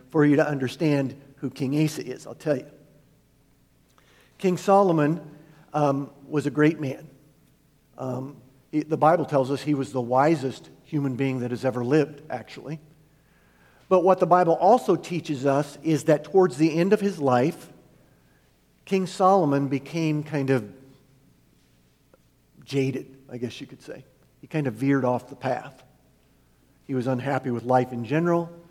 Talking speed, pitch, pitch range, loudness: 155 wpm, 145 Hz, 135-155 Hz, -24 LUFS